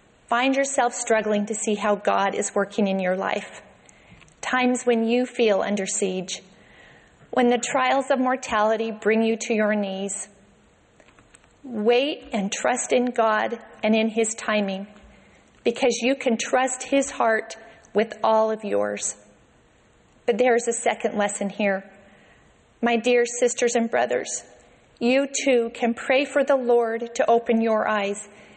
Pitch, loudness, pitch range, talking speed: 225 Hz, -23 LUFS, 210-245 Hz, 145 wpm